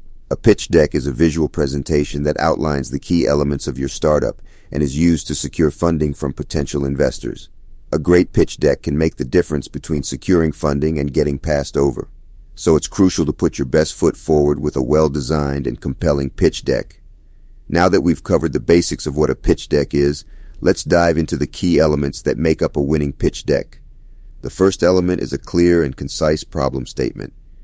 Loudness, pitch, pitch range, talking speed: -18 LUFS, 75 Hz, 70-80 Hz, 195 wpm